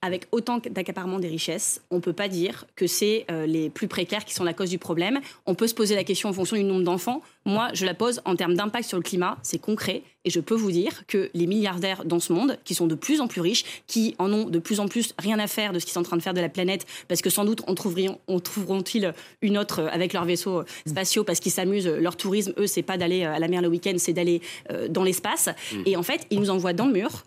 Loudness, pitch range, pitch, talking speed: -25 LUFS, 175-210 Hz, 185 Hz, 275 wpm